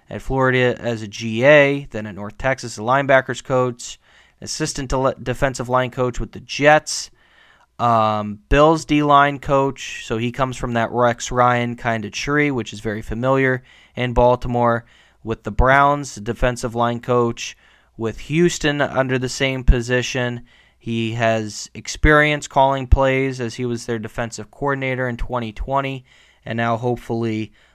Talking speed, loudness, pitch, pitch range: 150 wpm, -19 LUFS, 125 Hz, 115-135 Hz